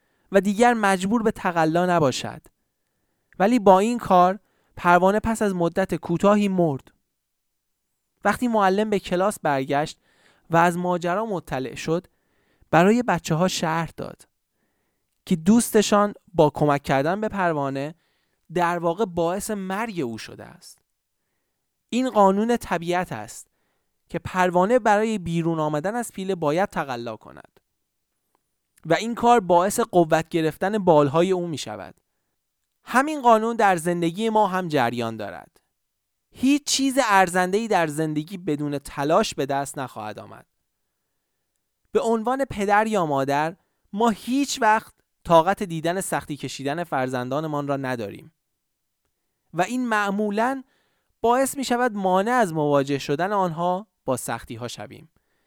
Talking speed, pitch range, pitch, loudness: 130 wpm, 150-210 Hz, 180 Hz, -22 LUFS